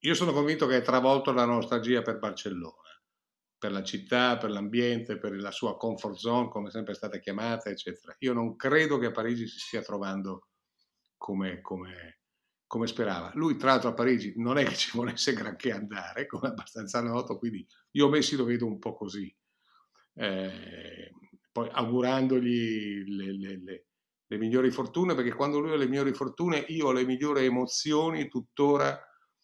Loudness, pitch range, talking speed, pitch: -29 LUFS, 105-130 Hz, 170 wpm, 120 Hz